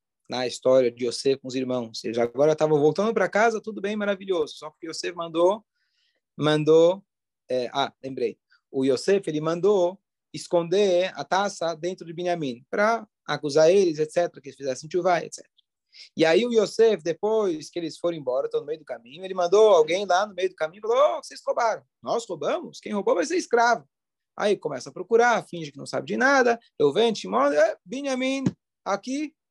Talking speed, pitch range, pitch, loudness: 190 wpm, 155-230 Hz, 180 Hz, -24 LUFS